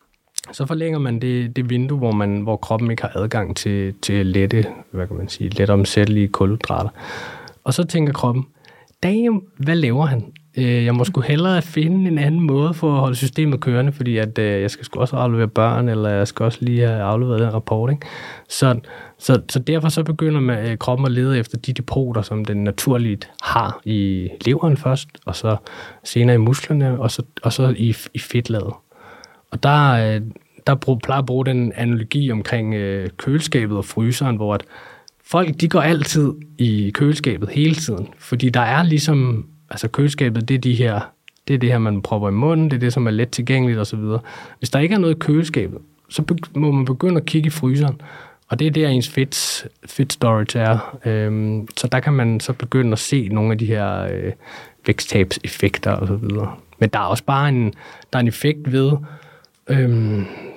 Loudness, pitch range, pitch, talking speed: -19 LUFS, 110-145 Hz, 125 Hz, 190 wpm